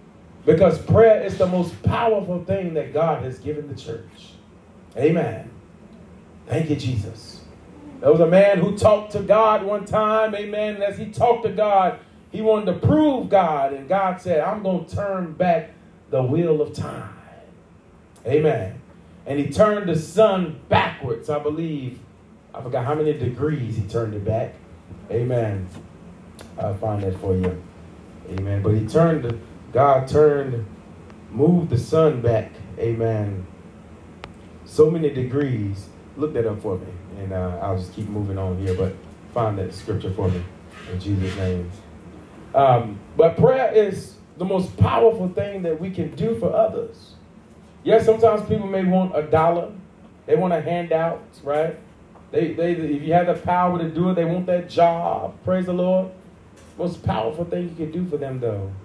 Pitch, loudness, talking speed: 150 Hz, -21 LUFS, 170 wpm